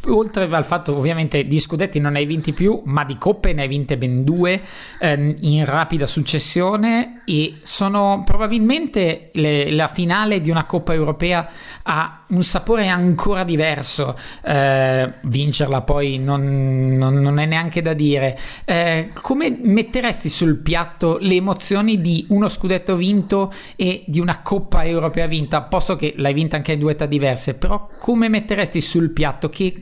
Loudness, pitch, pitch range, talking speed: -18 LUFS, 165 Hz, 150-190 Hz, 160 wpm